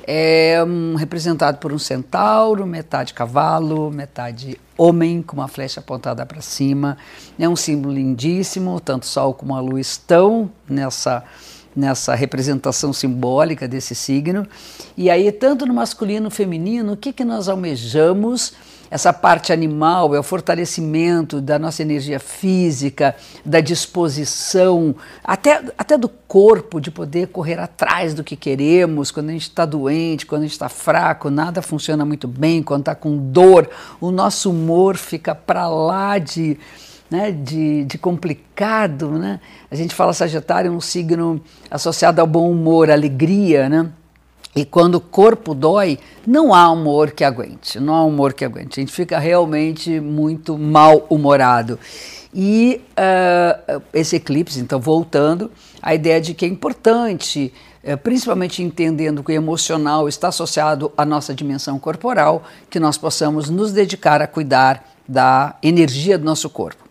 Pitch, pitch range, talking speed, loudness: 160 Hz, 145-175 Hz, 150 wpm, -16 LUFS